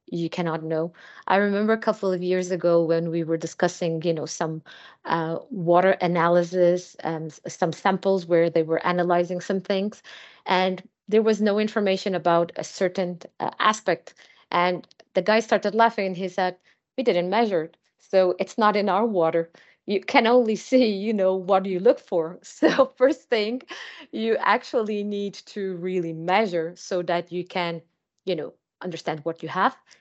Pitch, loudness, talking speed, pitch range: 185 Hz, -24 LUFS, 170 wpm, 170-210 Hz